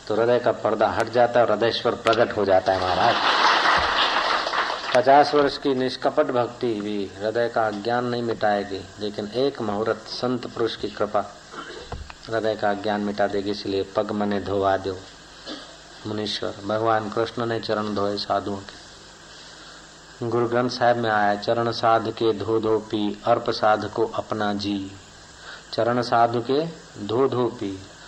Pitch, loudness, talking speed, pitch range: 110 Hz, -23 LUFS, 150 wpm, 100-120 Hz